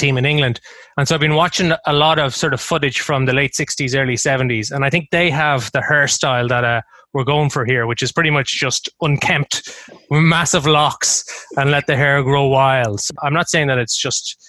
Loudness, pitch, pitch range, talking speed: -16 LUFS, 145 Hz, 130-155 Hz, 225 wpm